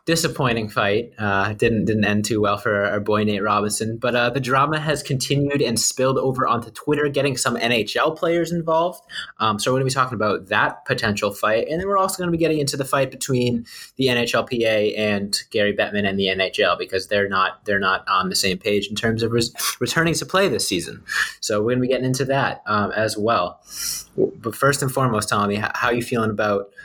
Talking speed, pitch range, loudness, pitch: 220 wpm, 105-140 Hz, -21 LUFS, 120 Hz